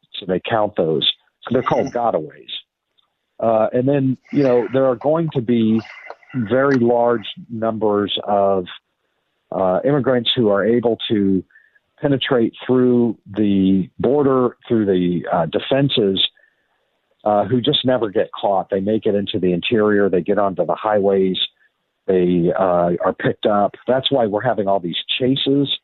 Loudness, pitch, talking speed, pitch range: -18 LUFS, 110 Hz, 150 wpm, 100-130 Hz